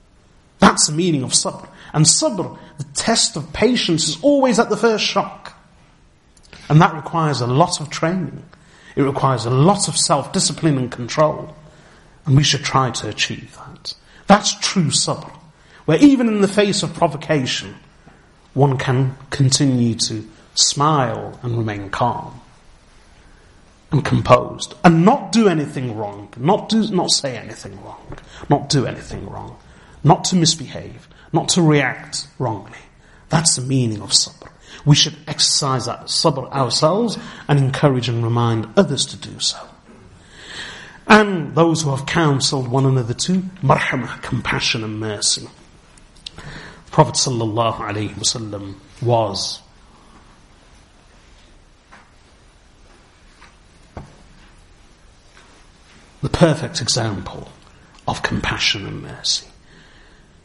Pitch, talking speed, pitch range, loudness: 145 Hz, 120 wpm, 120-165 Hz, -17 LUFS